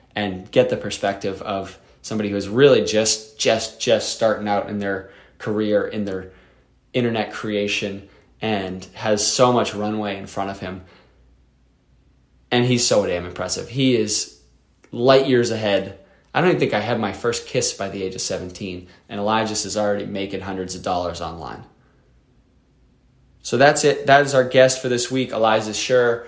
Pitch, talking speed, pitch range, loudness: 105 Hz, 170 wpm, 95-120 Hz, -20 LUFS